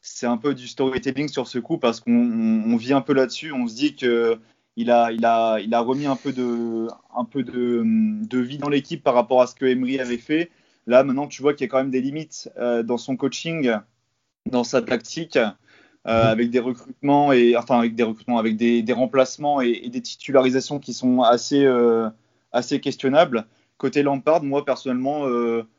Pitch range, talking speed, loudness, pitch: 120-140 Hz, 200 wpm, -21 LUFS, 130 Hz